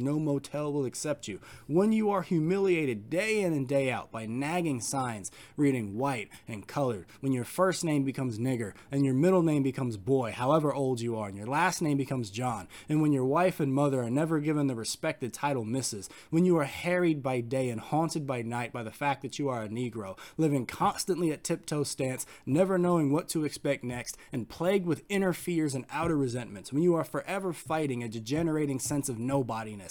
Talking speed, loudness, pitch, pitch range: 210 wpm, -30 LUFS, 140 Hz, 125-160 Hz